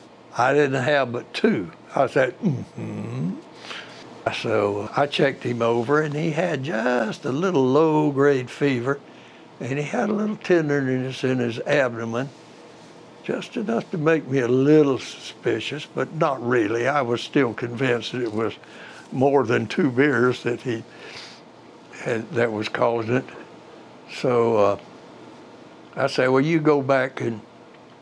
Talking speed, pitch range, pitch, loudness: 145 wpm, 120-150 Hz, 130 Hz, -22 LUFS